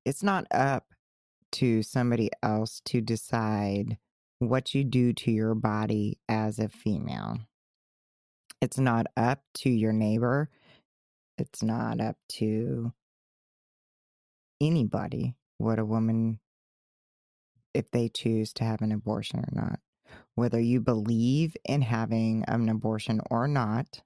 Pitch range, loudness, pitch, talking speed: 110-125 Hz, -29 LUFS, 115 Hz, 120 wpm